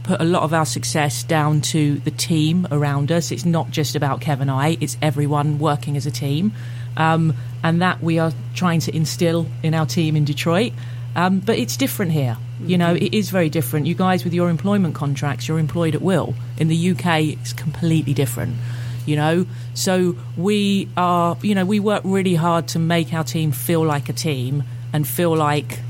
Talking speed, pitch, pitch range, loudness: 200 wpm, 155 Hz, 135-170 Hz, -20 LUFS